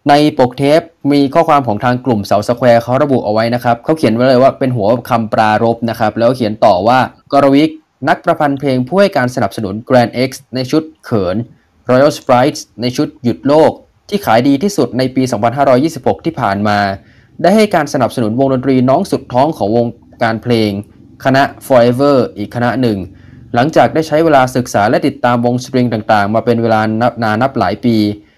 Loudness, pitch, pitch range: -12 LUFS, 125 Hz, 115-140 Hz